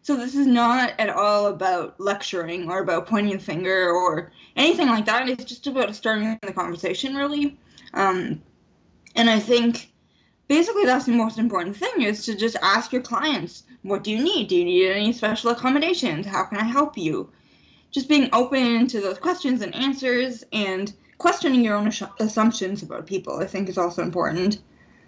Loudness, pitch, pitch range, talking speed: -22 LUFS, 225 Hz, 195-255 Hz, 180 wpm